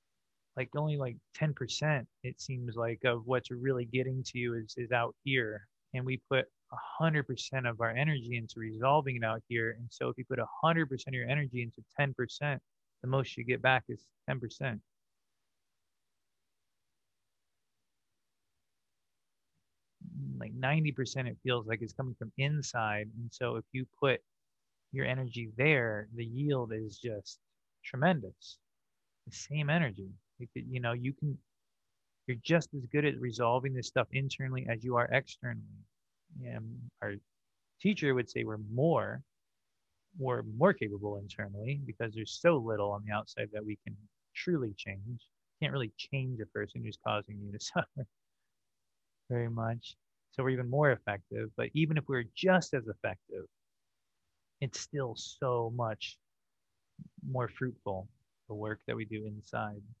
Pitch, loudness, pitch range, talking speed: 120 Hz, -35 LUFS, 105-130 Hz, 150 wpm